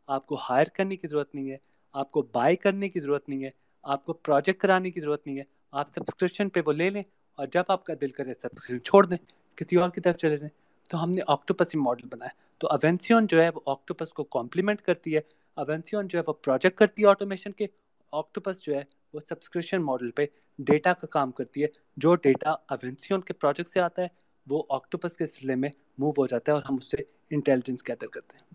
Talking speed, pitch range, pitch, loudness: 225 wpm, 140-180 Hz, 155 Hz, -27 LUFS